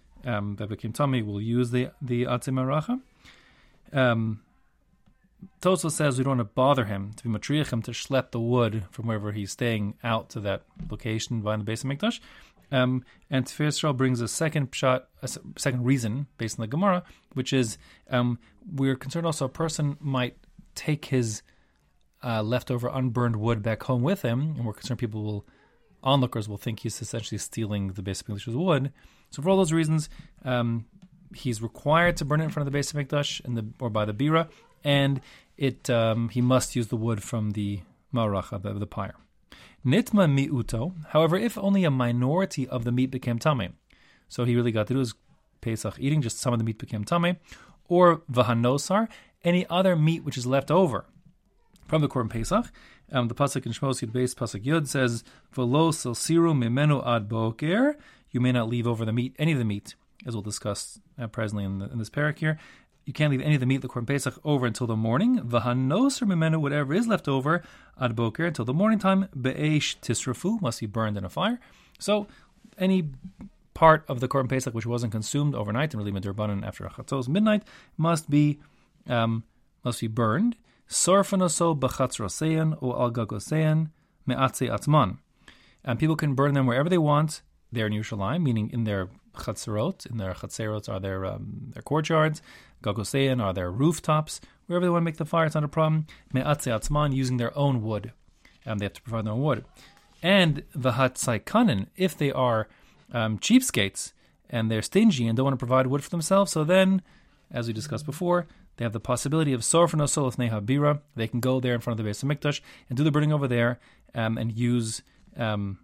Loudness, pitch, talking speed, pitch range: -26 LUFS, 130 Hz, 190 wpm, 115-155 Hz